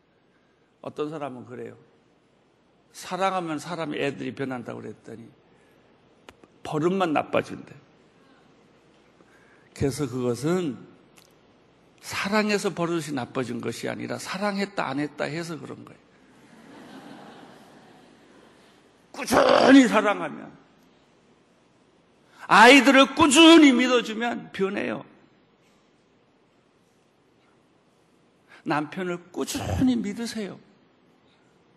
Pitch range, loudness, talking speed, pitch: 145-240 Hz, -22 LUFS, 185 characters per minute, 185 Hz